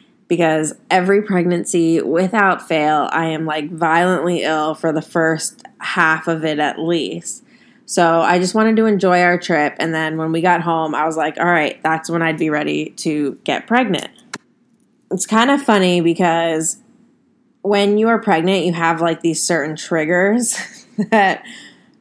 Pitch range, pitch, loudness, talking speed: 160-210 Hz, 175 Hz, -16 LUFS, 165 wpm